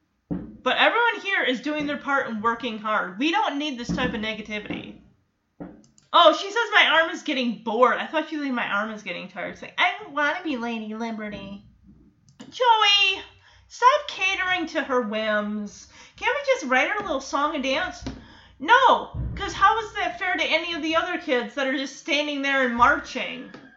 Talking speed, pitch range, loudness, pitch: 200 wpm, 240-345 Hz, -23 LUFS, 285 Hz